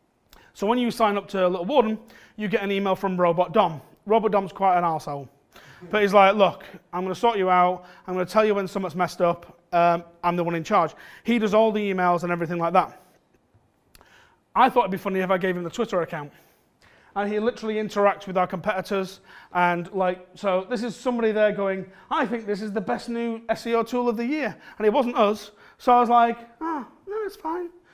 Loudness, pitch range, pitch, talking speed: -24 LUFS, 180-230 Hz, 200 Hz, 230 wpm